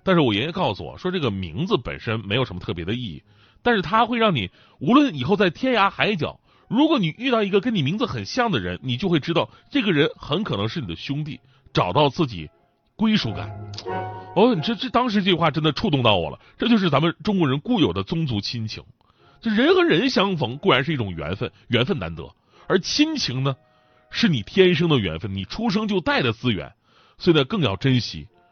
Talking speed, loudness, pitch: 320 characters per minute, -22 LUFS, 155 Hz